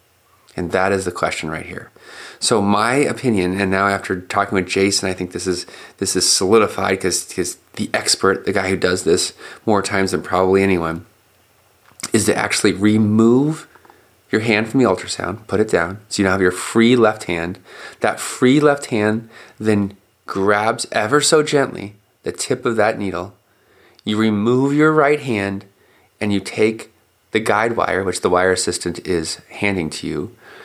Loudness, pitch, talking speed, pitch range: -18 LUFS, 100 Hz, 175 wpm, 95-110 Hz